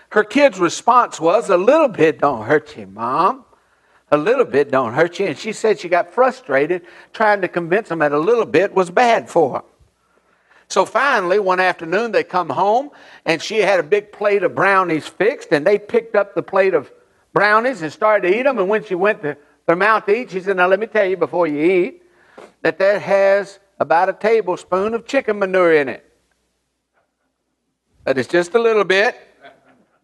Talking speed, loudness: 200 wpm, -17 LUFS